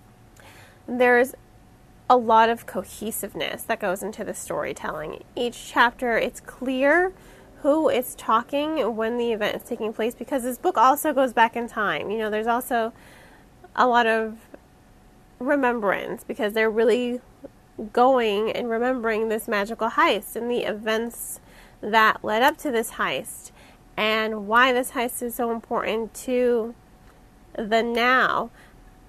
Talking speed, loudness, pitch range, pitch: 140 wpm, -23 LUFS, 220-250 Hz, 235 Hz